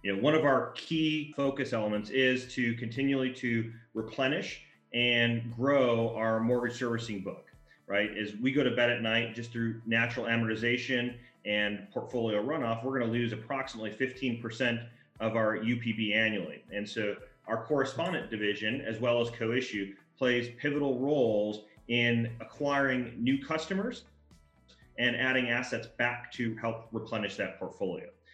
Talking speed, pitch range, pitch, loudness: 145 wpm, 110-130 Hz, 120 Hz, -31 LUFS